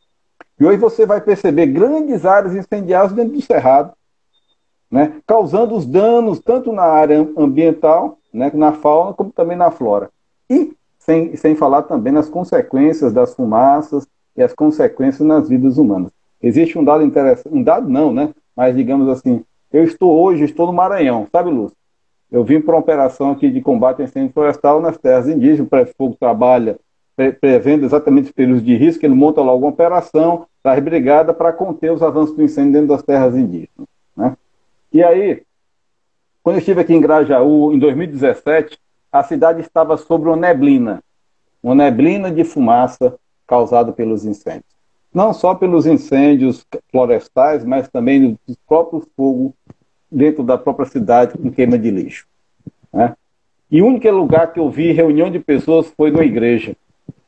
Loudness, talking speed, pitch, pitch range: -13 LUFS, 165 wpm, 160 Hz, 140-200 Hz